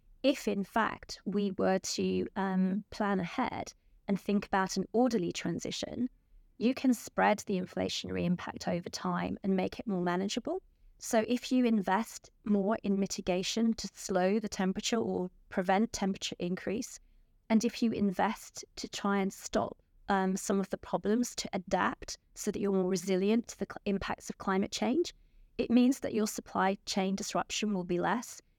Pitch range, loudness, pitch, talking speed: 190-230 Hz, -32 LUFS, 200 Hz, 170 wpm